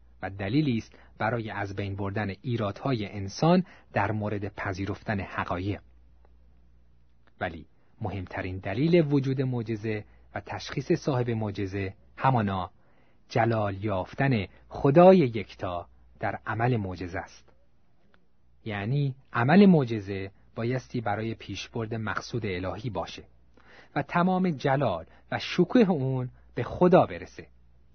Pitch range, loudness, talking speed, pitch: 95-130 Hz, -27 LUFS, 105 wpm, 105 Hz